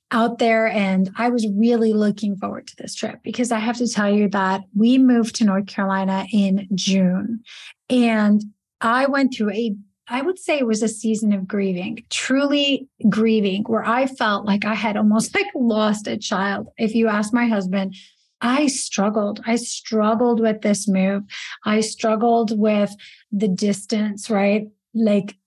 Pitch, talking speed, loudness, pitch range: 215 Hz, 165 wpm, -20 LUFS, 205-235 Hz